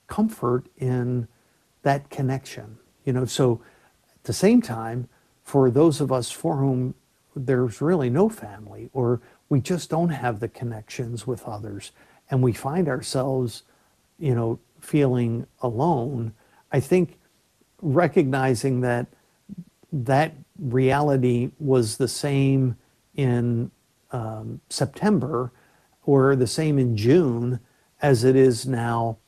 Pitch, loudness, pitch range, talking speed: 130 Hz, -23 LUFS, 120-145 Hz, 120 wpm